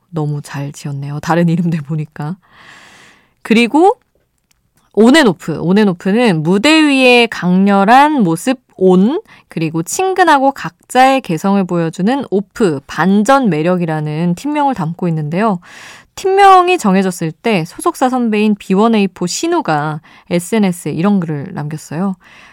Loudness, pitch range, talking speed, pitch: -13 LUFS, 165-250 Hz, 275 characters per minute, 195 Hz